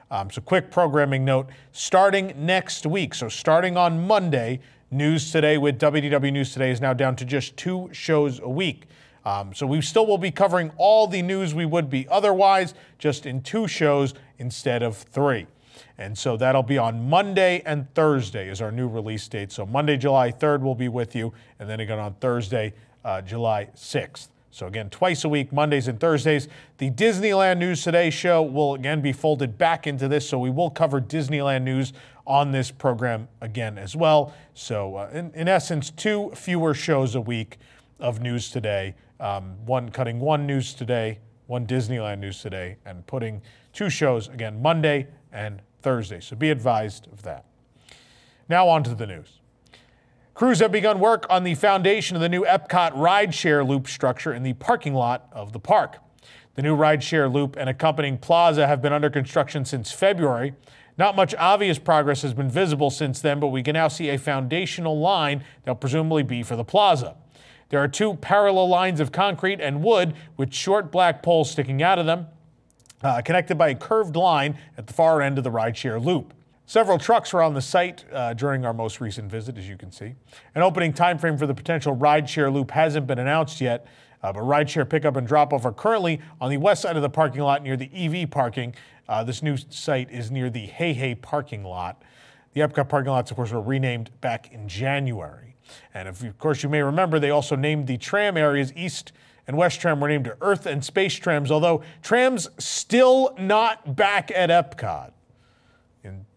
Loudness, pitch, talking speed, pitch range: -22 LUFS, 145 Hz, 190 wpm, 125-165 Hz